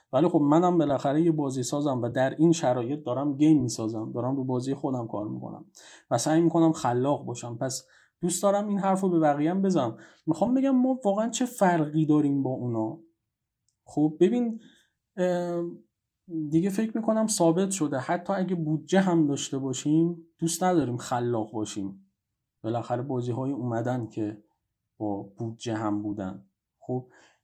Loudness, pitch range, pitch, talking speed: -27 LUFS, 120-170 Hz, 145 Hz, 155 wpm